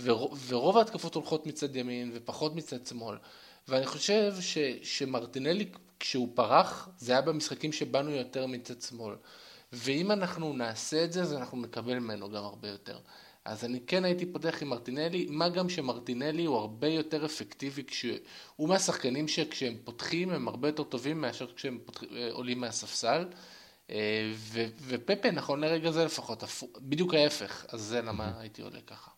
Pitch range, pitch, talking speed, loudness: 120-160 Hz, 135 Hz, 150 wpm, -32 LUFS